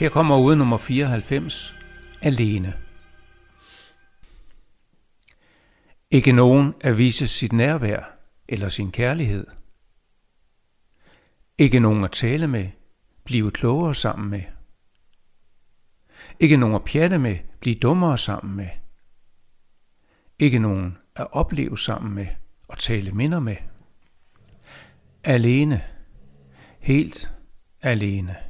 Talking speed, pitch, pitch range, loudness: 95 wpm, 105 Hz, 95-130 Hz, -21 LUFS